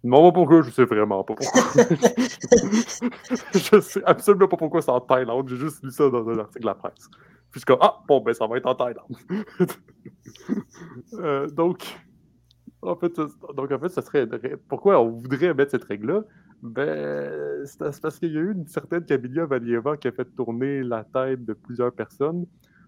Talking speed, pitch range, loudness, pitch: 185 wpm, 125-175 Hz, -22 LUFS, 140 Hz